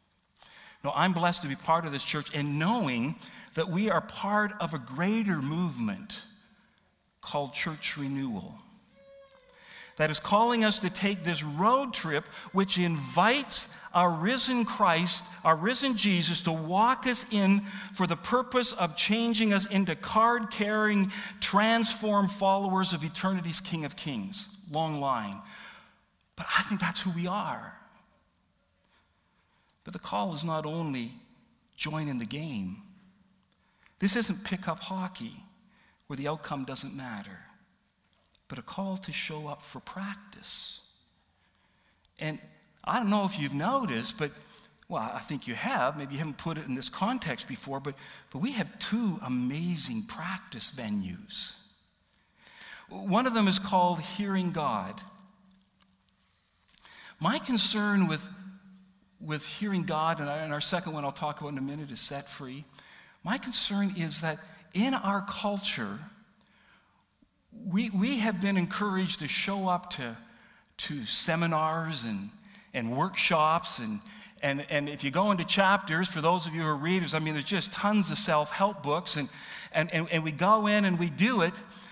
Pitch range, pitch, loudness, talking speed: 155-205 Hz, 185 Hz, -29 LUFS, 150 wpm